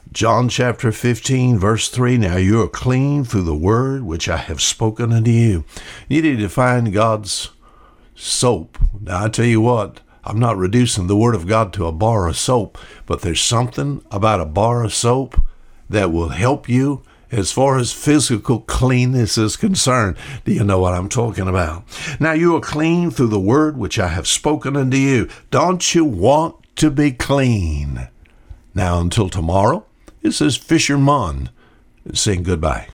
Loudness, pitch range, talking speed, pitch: -17 LUFS, 95-130 Hz, 175 wpm, 115 Hz